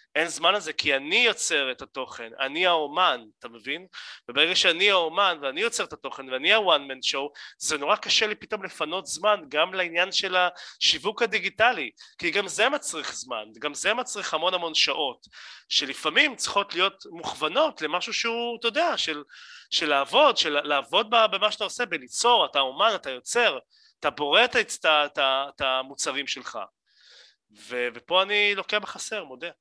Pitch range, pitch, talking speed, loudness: 140-210 Hz, 180 Hz, 160 wpm, -24 LUFS